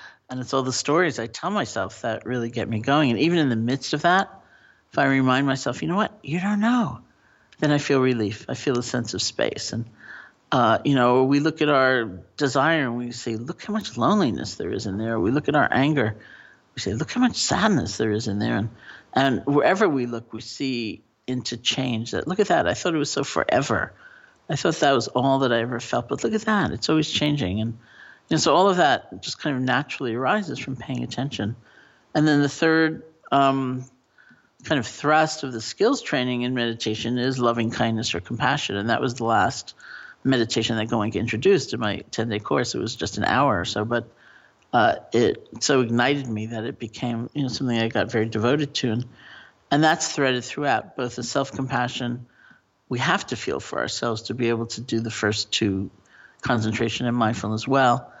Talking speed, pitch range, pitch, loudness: 215 wpm, 115-140 Hz, 125 Hz, -23 LUFS